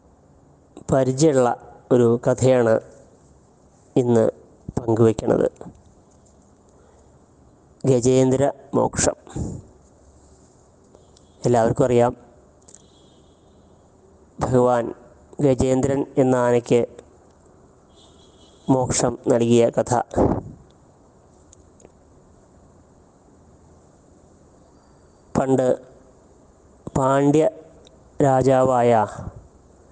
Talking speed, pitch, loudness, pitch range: 40 wpm, 115 Hz, -20 LUFS, 80-130 Hz